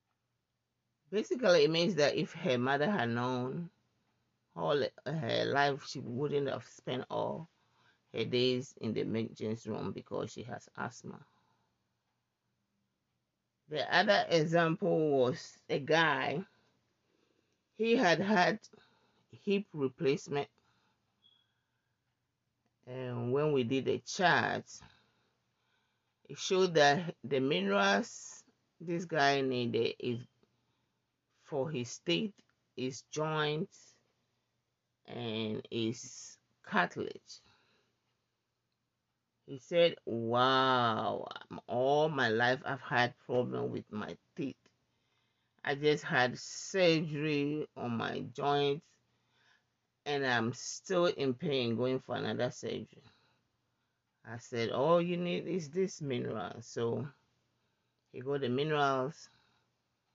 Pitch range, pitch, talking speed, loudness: 120-155 Hz, 130 Hz, 100 wpm, -33 LUFS